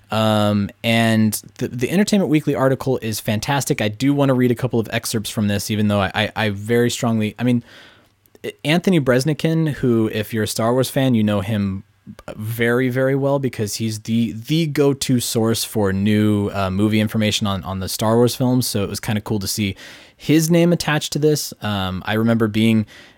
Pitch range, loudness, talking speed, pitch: 105-130 Hz, -19 LUFS, 205 wpm, 115 Hz